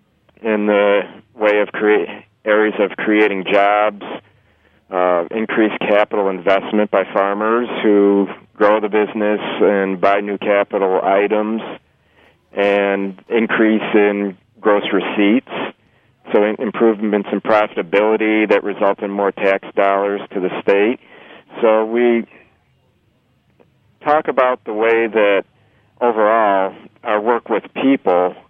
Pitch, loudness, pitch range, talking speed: 105 Hz, -16 LUFS, 100-110 Hz, 115 wpm